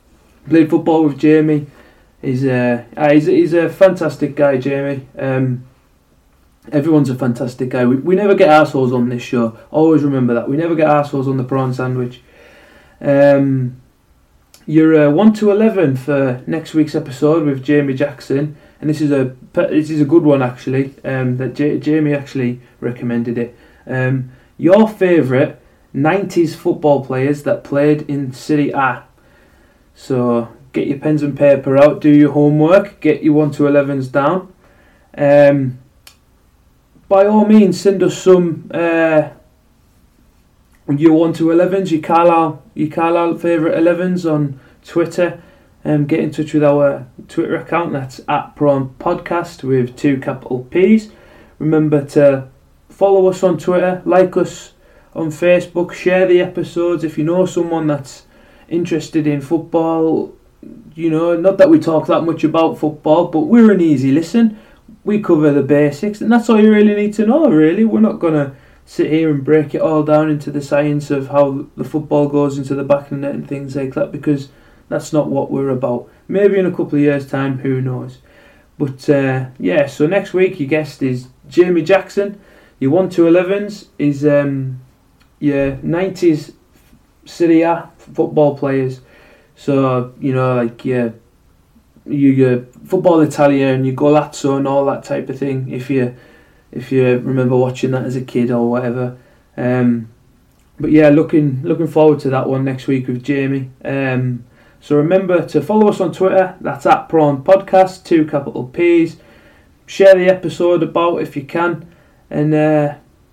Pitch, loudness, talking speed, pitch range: 145 Hz, -14 LUFS, 165 wpm, 130-170 Hz